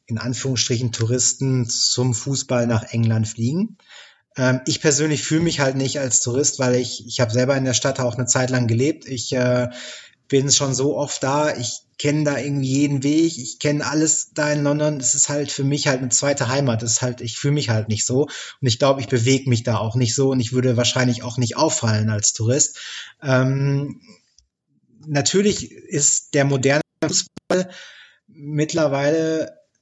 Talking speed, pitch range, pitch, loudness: 185 wpm, 125-145 Hz, 135 Hz, -20 LUFS